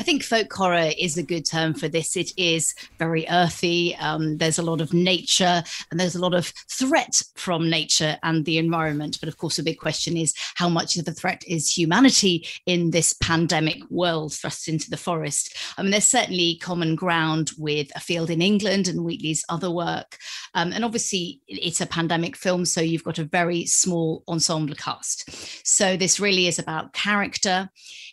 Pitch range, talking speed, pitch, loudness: 160-180 Hz, 190 wpm, 170 Hz, -22 LUFS